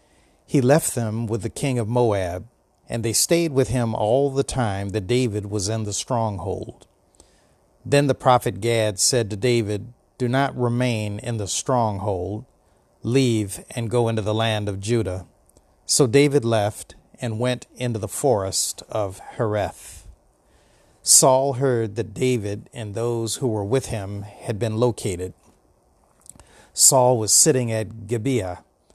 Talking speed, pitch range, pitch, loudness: 145 wpm, 105-125 Hz, 115 Hz, -21 LUFS